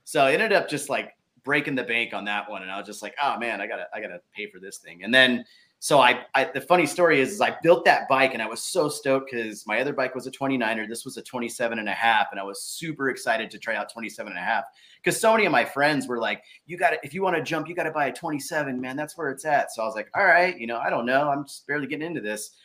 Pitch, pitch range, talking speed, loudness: 135 Hz, 115-150 Hz, 315 wpm, -24 LUFS